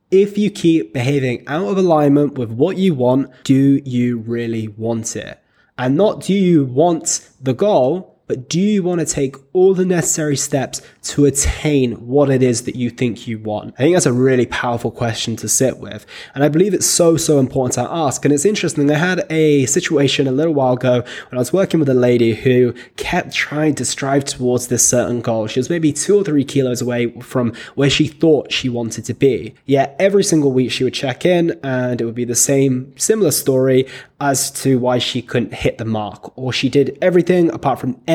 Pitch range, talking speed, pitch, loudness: 125-155 Hz, 210 wpm, 135 Hz, -16 LUFS